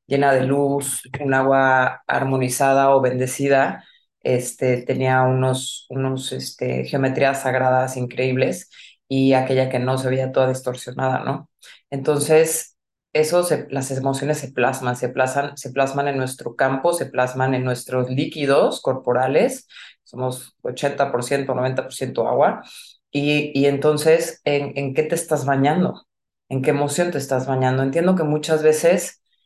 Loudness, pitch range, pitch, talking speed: -20 LUFS, 130-145 Hz, 135 Hz, 140 wpm